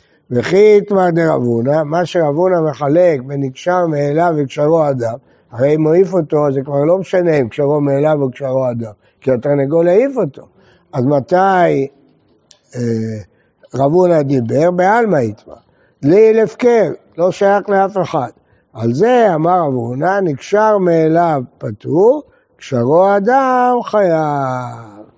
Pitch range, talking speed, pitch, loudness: 135-185 Hz, 135 wpm, 160 Hz, -14 LUFS